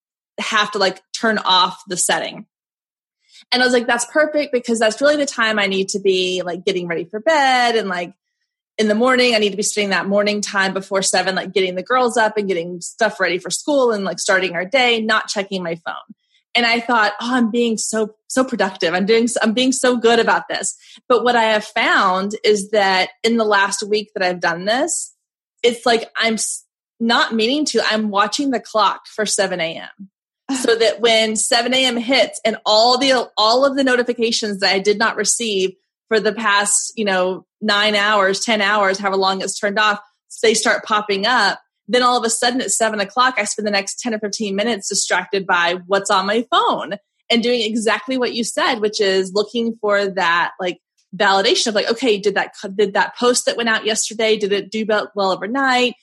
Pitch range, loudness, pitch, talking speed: 200-240 Hz, -17 LUFS, 215 Hz, 210 wpm